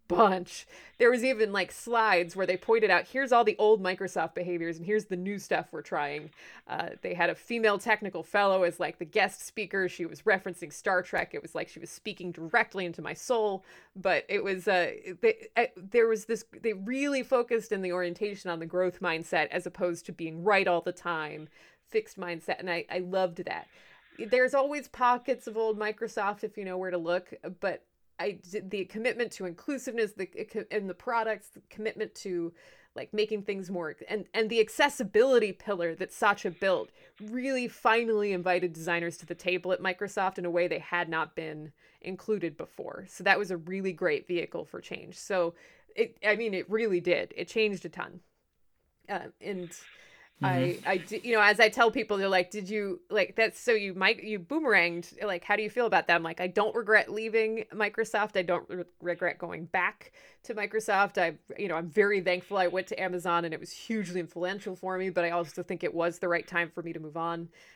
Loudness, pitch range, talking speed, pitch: -30 LUFS, 175-220 Hz, 205 wpm, 195 Hz